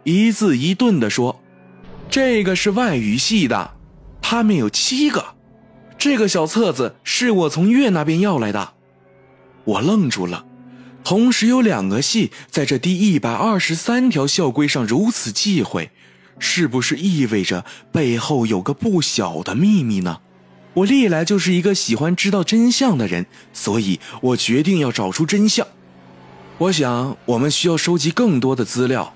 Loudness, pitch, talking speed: -17 LUFS, 160 Hz, 230 characters per minute